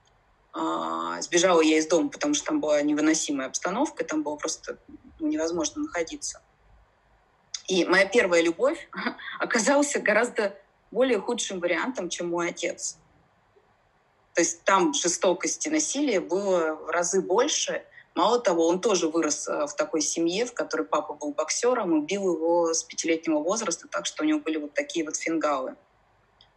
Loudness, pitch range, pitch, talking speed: -25 LUFS, 155-240 Hz, 170 Hz, 145 wpm